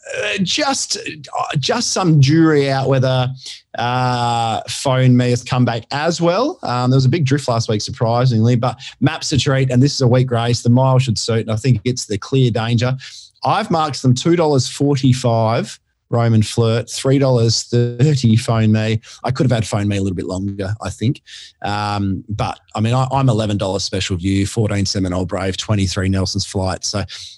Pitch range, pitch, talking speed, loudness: 105-130 Hz, 120 Hz, 195 wpm, -17 LUFS